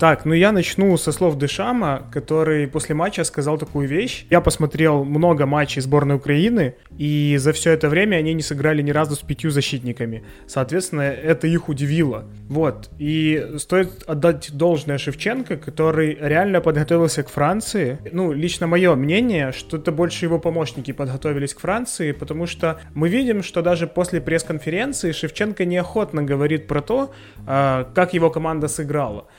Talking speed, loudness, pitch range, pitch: 155 wpm, -20 LUFS, 145-170 Hz, 155 Hz